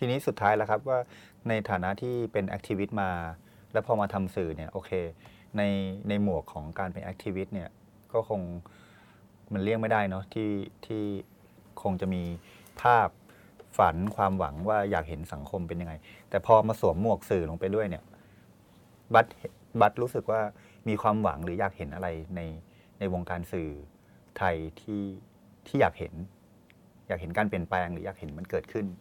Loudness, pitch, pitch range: -30 LUFS, 100 Hz, 90-105 Hz